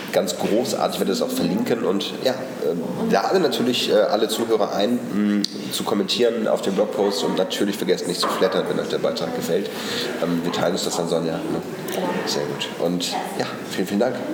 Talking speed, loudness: 175 wpm, -22 LUFS